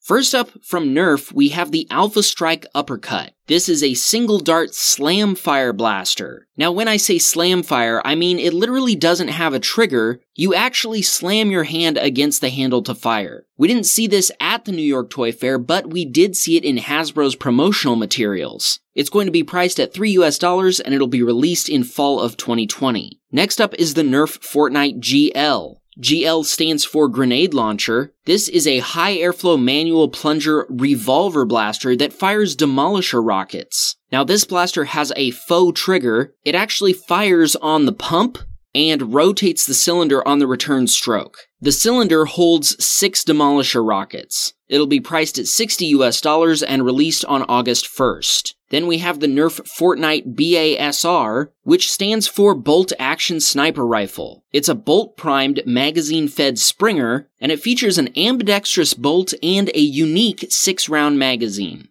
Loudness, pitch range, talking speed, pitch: -16 LUFS, 140-190 Hz, 165 wpm, 160 Hz